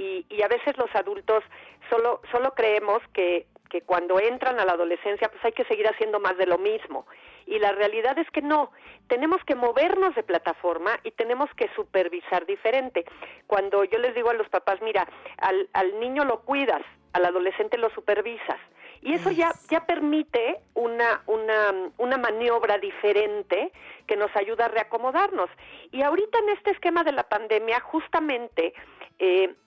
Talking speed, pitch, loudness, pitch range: 170 wpm, 235 Hz, -25 LUFS, 205-325 Hz